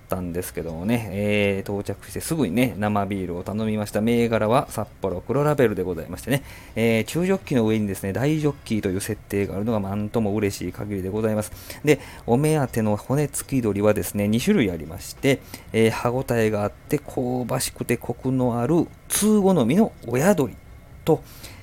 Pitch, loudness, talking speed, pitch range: 110 Hz, -23 LUFS, 375 characters per minute, 100-130 Hz